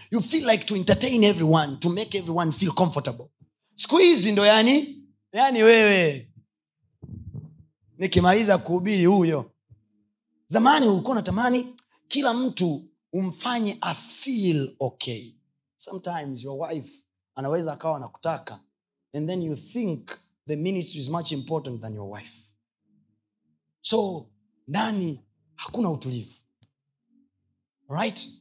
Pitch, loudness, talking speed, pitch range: 160 Hz, -23 LUFS, 110 wpm, 125-205 Hz